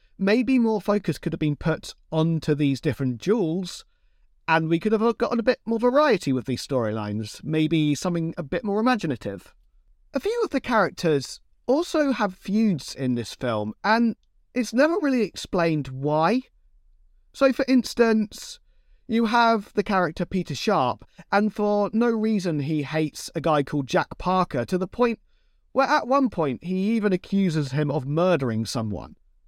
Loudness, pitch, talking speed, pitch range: -24 LUFS, 185 Hz, 165 wpm, 150-230 Hz